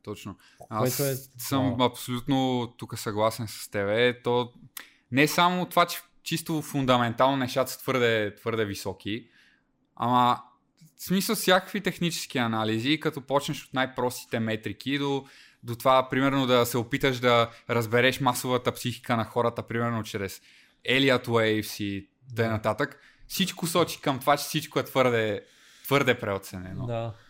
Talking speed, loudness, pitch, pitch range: 140 wpm, -26 LUFS, 125 Hz, 115-140 Hz